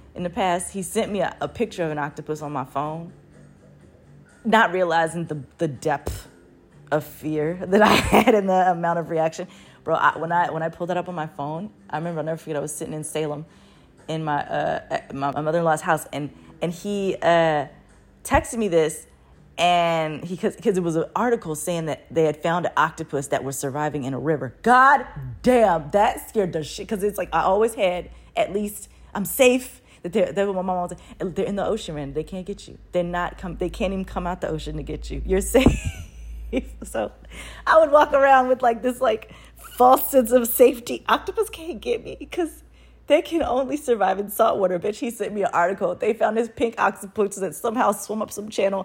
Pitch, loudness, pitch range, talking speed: 180 Hz, -22 LUFS, 155-220 Hz, 215 wpm